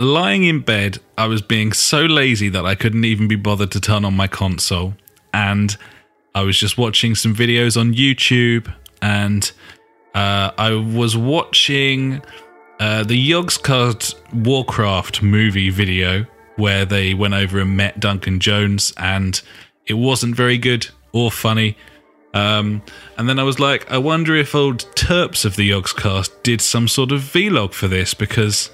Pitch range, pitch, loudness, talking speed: 100-120 Hz, 110 Hz, -16 LUFS, 160 wpm